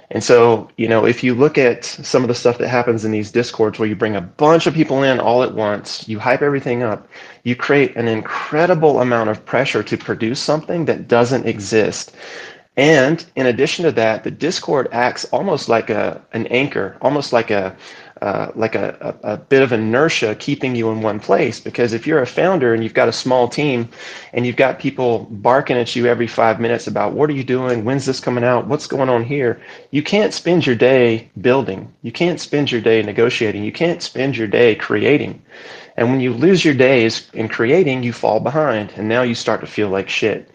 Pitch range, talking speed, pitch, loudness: 115-140 Hz, 215 wpm, 120 Hz, -16 LUFS